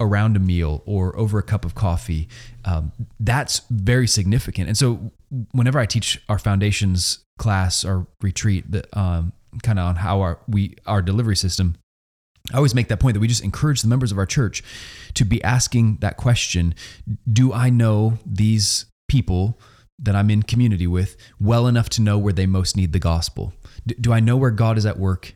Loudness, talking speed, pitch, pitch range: -20 LUFS, 190 wpm, 105 Hz, 95-115 Hz